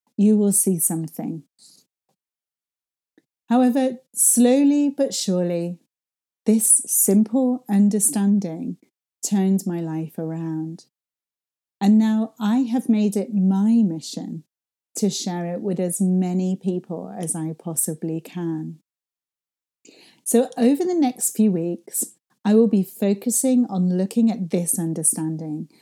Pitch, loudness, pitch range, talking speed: 195 Hz, -20 LUFS, 175-230 Hz, 115 wpm